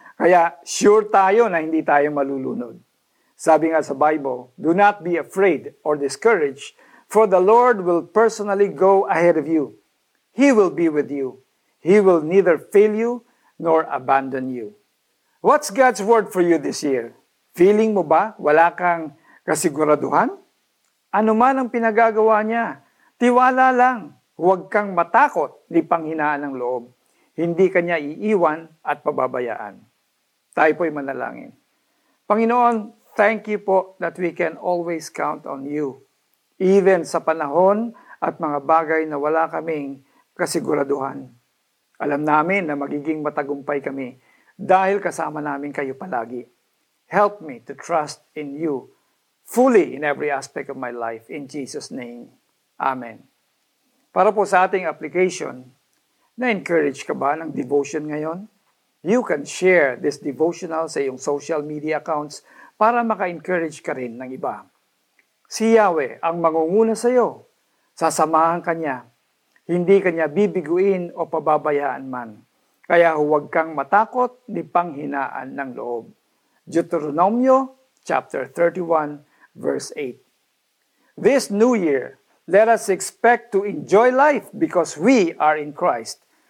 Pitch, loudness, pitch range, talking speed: 170 Hz, -19 LUFS, 150-210 Hz, 135 wpm